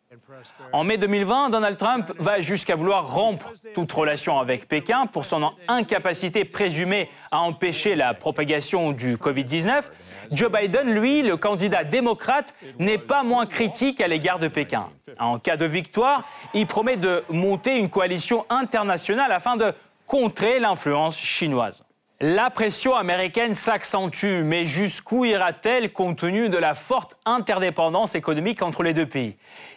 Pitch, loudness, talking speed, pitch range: 195 Hz, -22 LUFS, 145 wpm, 165-225 Hz